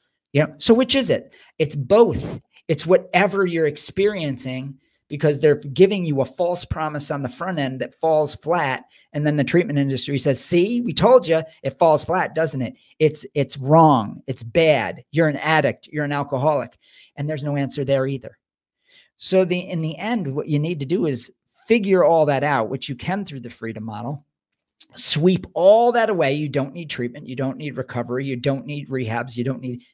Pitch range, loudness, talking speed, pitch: 135-175 Hz, -20 LUFS, 200 wpm, 150 Hz